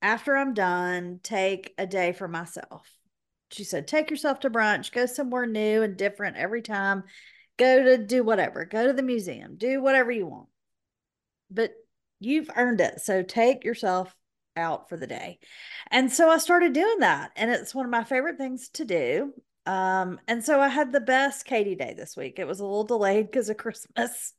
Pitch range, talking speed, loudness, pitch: 195-270 Hz, 190 wpm, -25 LUFS, 235 Hz